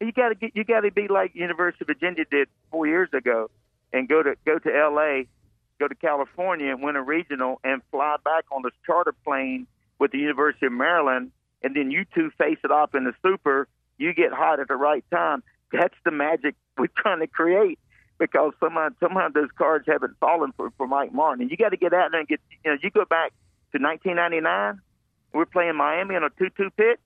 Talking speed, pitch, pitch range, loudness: 220 wpm, 150 Hz, 135-180 Hz, -24 LUFS